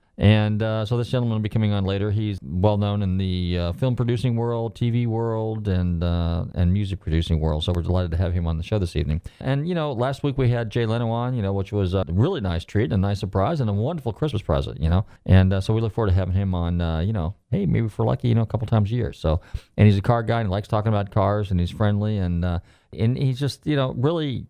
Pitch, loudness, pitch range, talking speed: 105 Hz, -23 LUFS, 90-115 Hz, 280 wpm